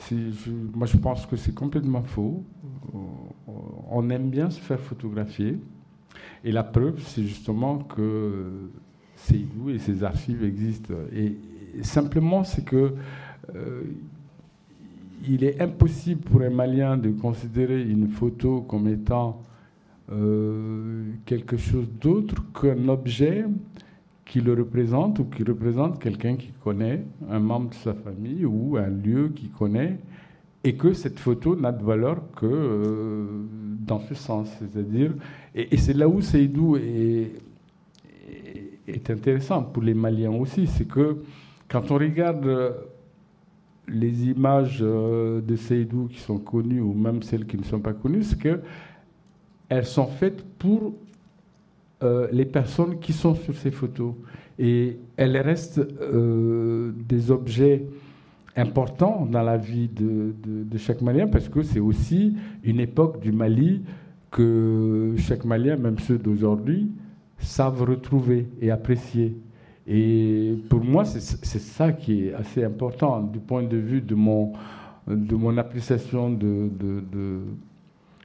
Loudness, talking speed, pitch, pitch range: -24 LUFS, 135 wpm, 120 Hz, 110-145 Hz